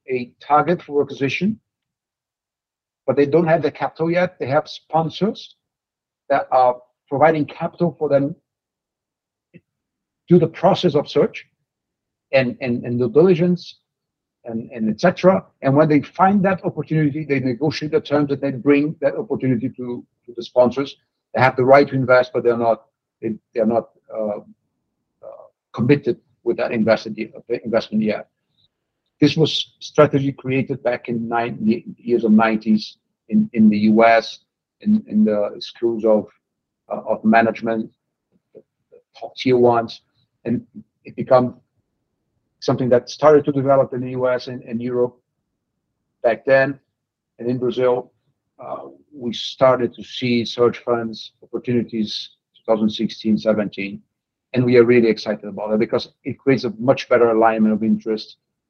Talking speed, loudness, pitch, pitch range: 145 wpm, -19 LUFS, 125 Hz, 115-150 Hz